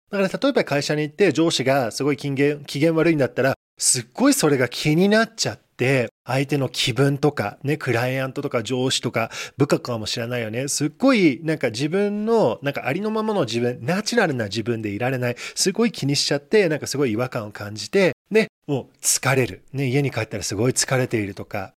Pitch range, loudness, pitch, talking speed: 125-165 Hz, -21 LUFS, 140 Hz, 420 characters per minute